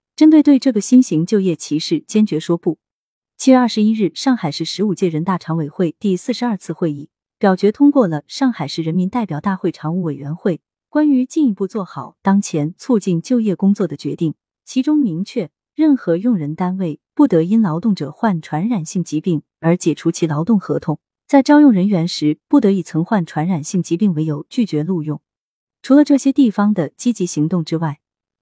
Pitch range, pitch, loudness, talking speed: 160-230 Hz, 185 Hz, -17 LUFS, 300 characters per minute